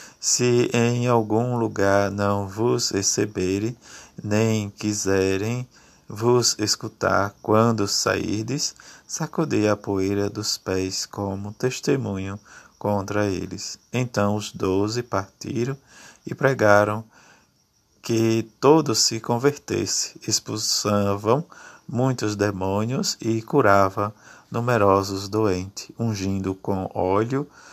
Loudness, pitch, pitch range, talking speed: -23 LUFS, 110 Hz, 100-120 Hz, 90 wpm